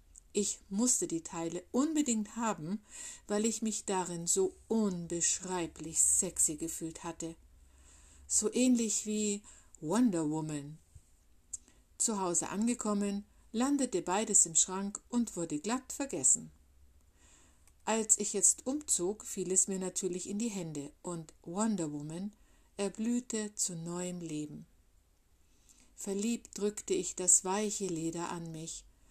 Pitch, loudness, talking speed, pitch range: 180 Hz, -32 LUFS, 120 wpm, 155-215 Hz